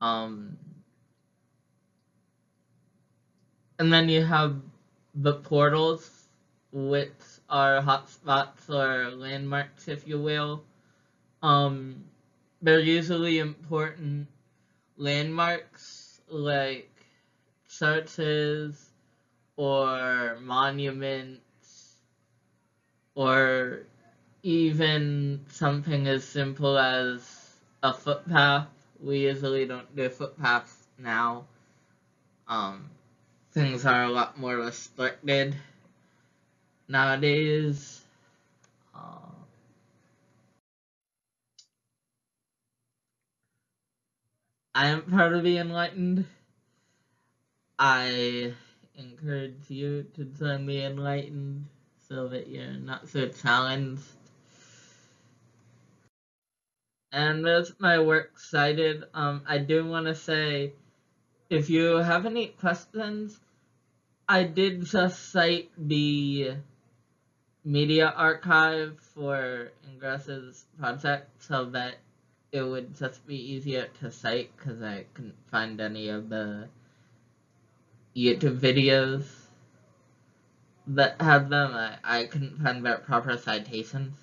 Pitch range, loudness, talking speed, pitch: 125-150 Hz, -27 LUFS, 85 wpm, 140 Hz